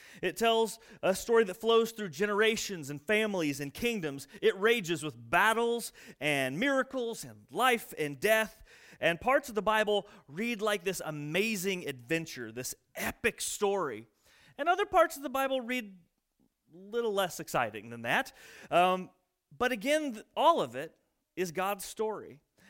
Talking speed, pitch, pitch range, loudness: 150 wpm, 205 Hz, 170-230 Hz, -31 LUFS